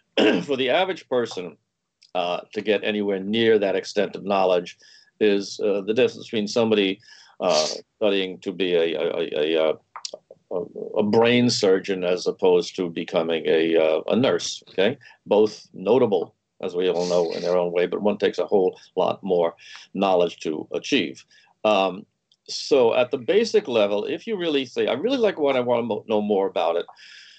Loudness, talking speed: -22 LUFS, 175 wpm